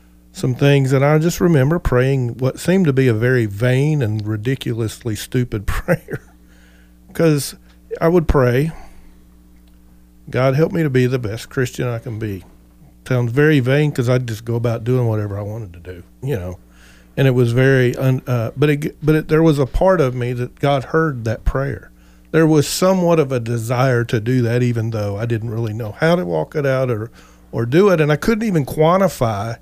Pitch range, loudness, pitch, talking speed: 110-145 Hz, -17 LUFS, 125 Hz, 200 wpm